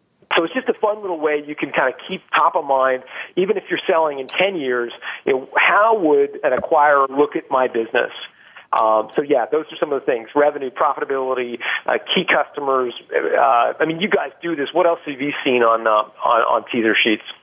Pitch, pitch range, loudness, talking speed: 145 Hz, 130-175 Hz, -18 LUFS, 220 wpm